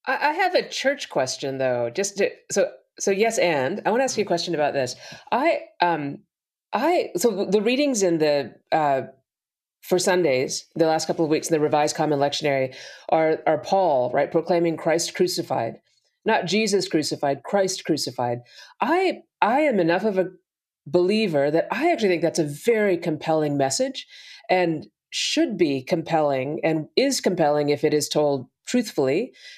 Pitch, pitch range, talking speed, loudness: 170 Hz, 150-215 Hz, 165 wpm, -23 LUFS